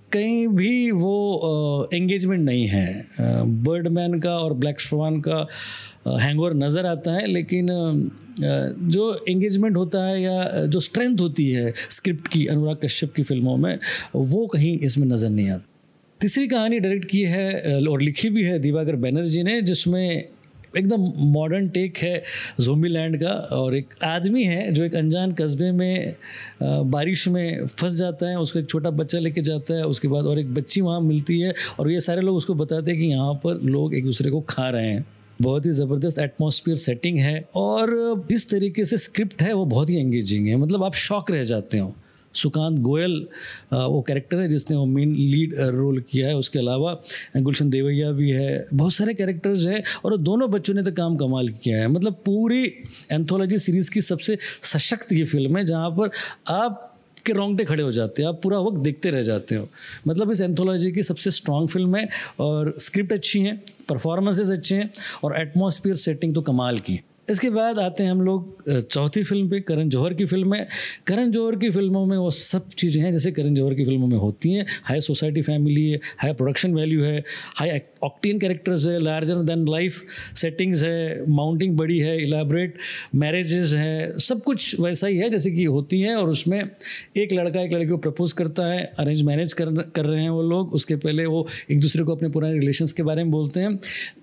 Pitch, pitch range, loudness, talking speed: 165 Hz, 150-190 Hz, -22 LUFS, 195 wpm